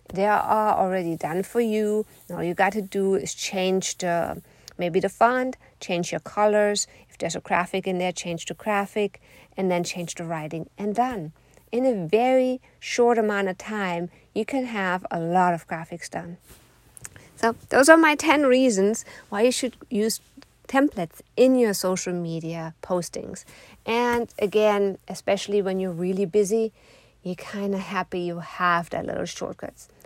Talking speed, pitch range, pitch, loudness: 160 wpm, 180-225 Hz, 200 Hz, -24 LUFS